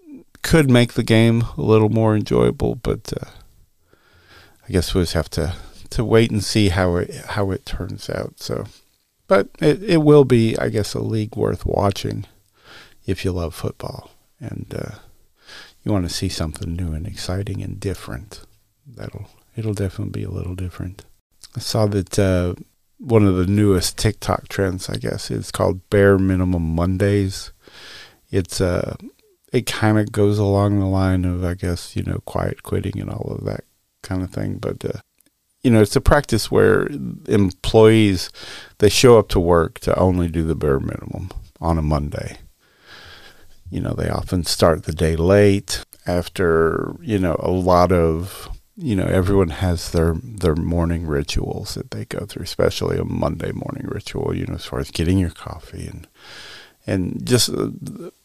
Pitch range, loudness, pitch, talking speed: 90-110 Hz, -19 LUFS, 100 Hz, 175 wpm